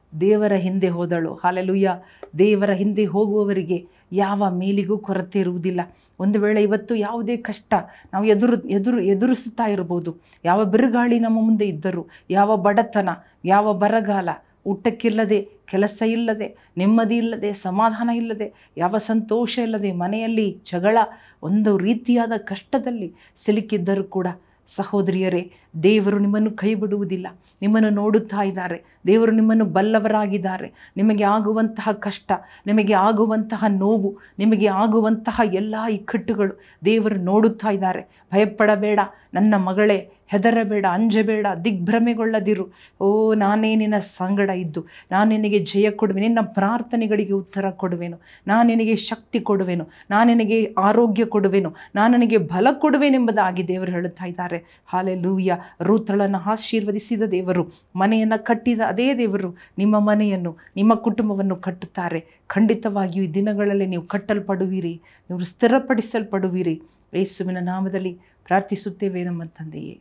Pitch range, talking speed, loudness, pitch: 190-220 Hz, 110 wpm, -20 LUFS, 205 Hz